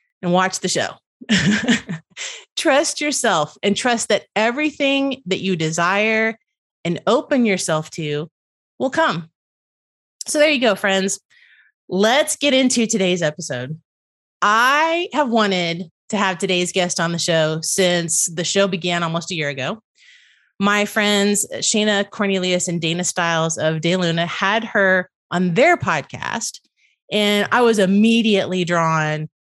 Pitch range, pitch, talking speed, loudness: 170-230 Hz, 195 Hz, 135 wpm, -18 LUFS